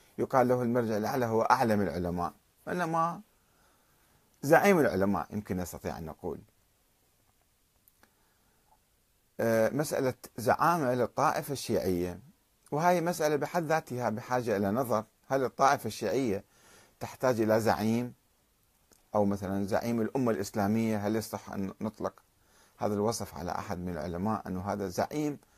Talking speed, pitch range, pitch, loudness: 115 wpm, 100-125 Hz, 110 Hz, -30 LUFS